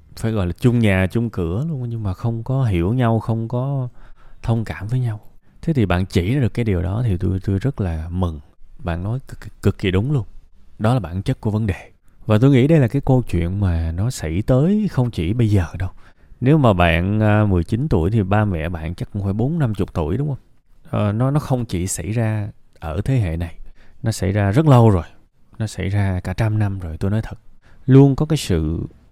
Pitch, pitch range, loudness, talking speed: 105 Hz, 95-125 Hz, -19 LUFS, 235 wpm